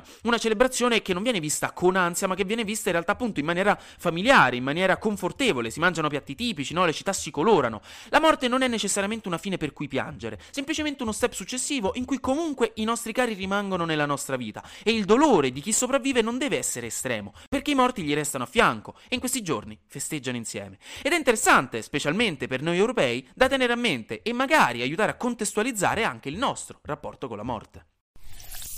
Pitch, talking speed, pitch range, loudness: 200 Hz, 210 wpm, 150-245 Hz, -25 LUFS